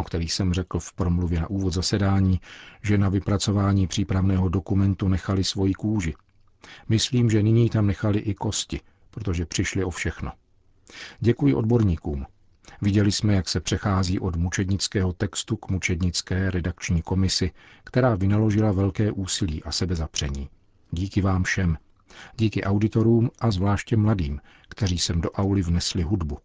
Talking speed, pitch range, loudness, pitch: 140 wpm, 90-105 Hz, -24 LUFS, 95 Hz